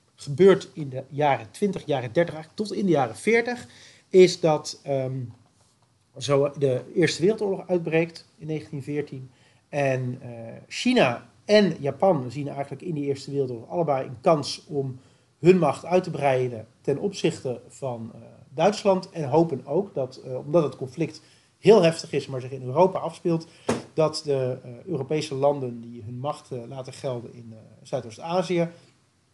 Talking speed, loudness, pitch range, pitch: 160 wpm, -25 LUFS, 125-165 Hz, 140 Hz